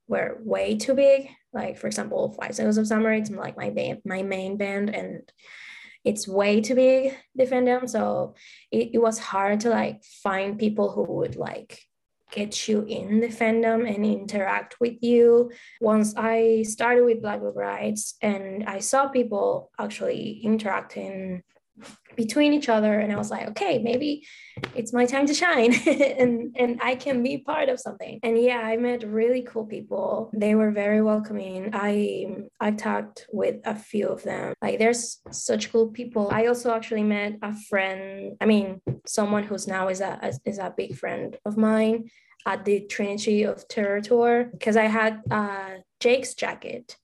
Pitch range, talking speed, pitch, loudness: 205-240 Hz, 170 wpm, 220 Hz, -24 LUFS